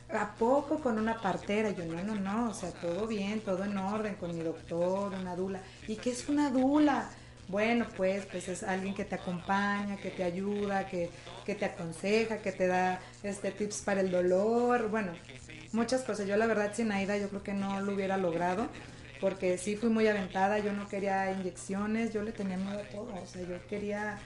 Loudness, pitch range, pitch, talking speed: -33 LUFS, 185-215 Hz, 200 Hz, 205 wpm